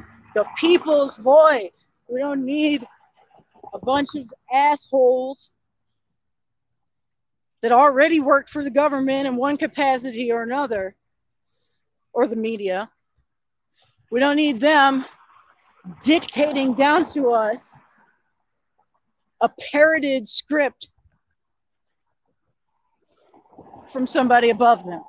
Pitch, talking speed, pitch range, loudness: 275 Hz, 95 wpm, 240-295 Hz, -19 LUFS